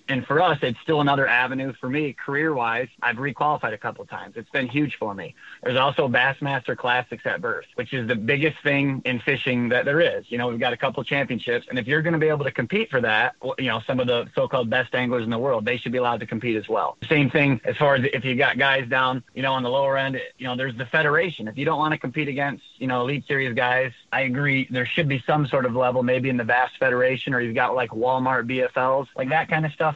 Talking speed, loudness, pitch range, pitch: 260 wpm, -23 LUFS, 125-145 Hz, 130 Hz